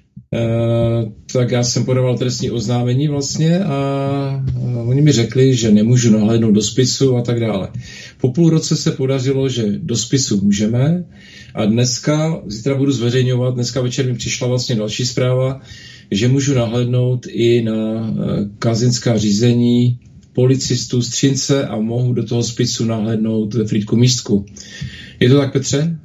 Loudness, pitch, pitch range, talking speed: -16 LUFS, 125 Hz, 115-135 Hz, 145 wpm